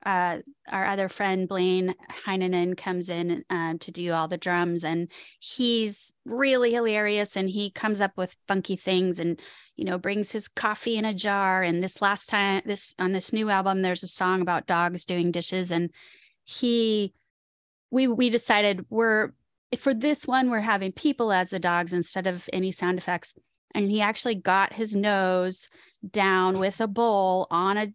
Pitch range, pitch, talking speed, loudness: 180-215 Hz, 195 Hz, 175 wpm, -26 LUFS